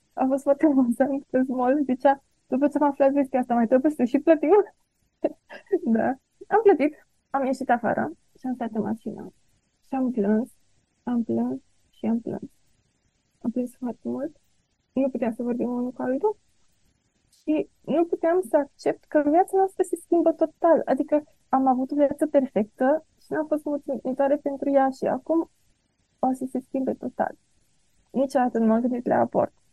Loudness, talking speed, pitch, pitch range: -24 LUFS, 170 wpm, 270 Hz, 250-305 Hz